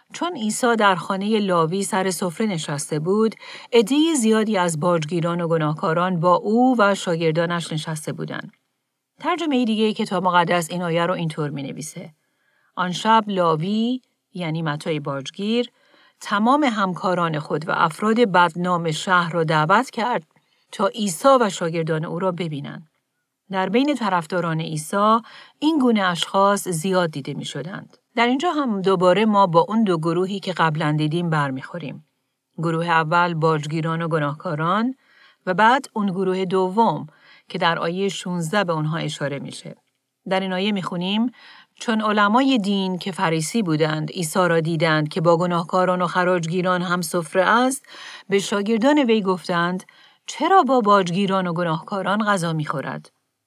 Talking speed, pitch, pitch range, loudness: 145 wpm, 185 Hz, 165-215 Hz, -21 LUFS